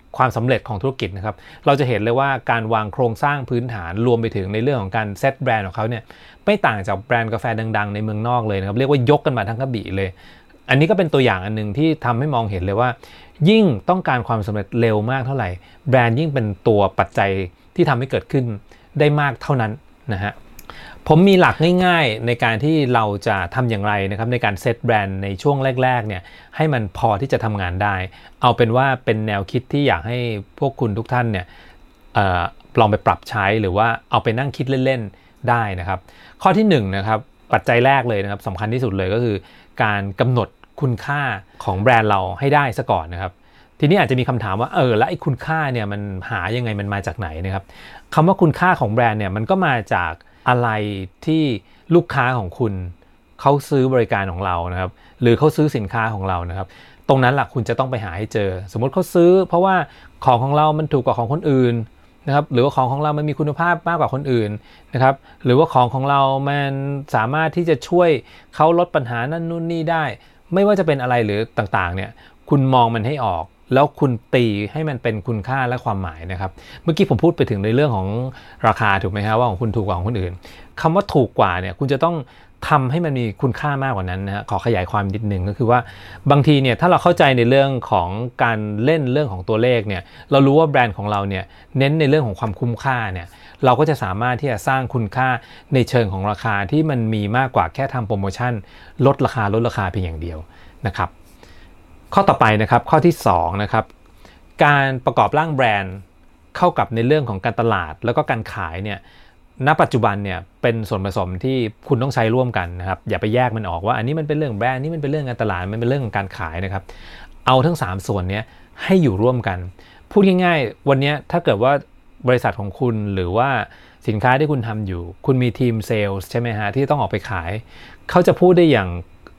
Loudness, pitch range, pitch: -19 LUFS, 100-140 Hz, 120 Hz